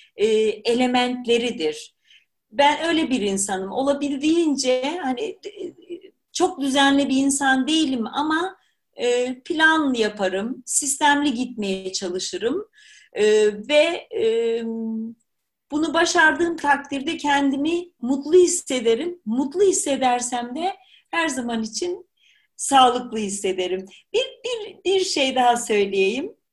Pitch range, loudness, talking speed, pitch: 245-350 Hz, -21 LUFS, 90 wpm, 285 Hz